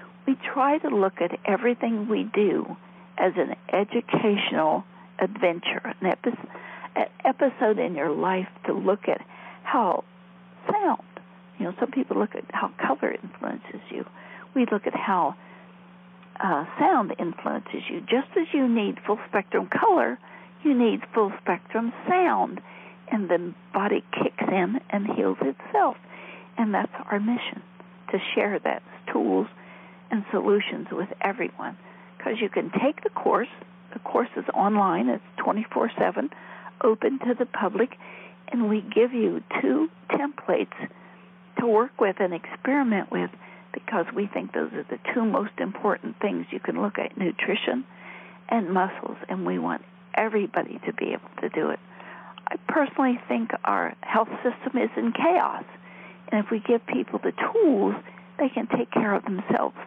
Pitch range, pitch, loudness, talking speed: 185-250 Hz, 215 Hz, -26 LUFS, 150 wpm